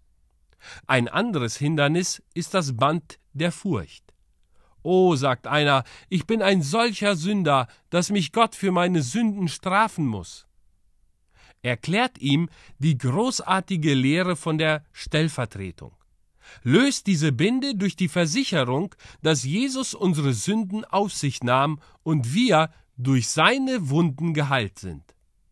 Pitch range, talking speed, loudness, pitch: 130-190 Hz, 125 wpm, -23 LUFS, 160 Hz